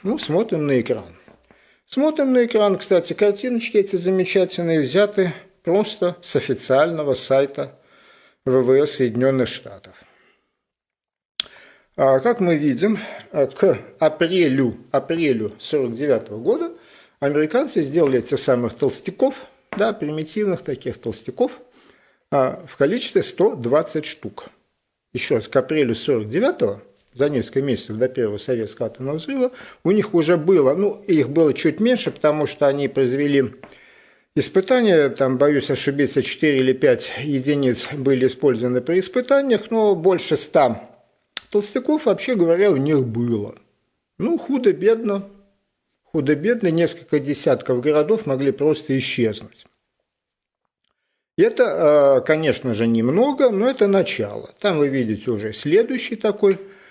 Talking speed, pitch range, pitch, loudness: 115 wpm, 135-210 Hz, 165 Hz, -20 LUFS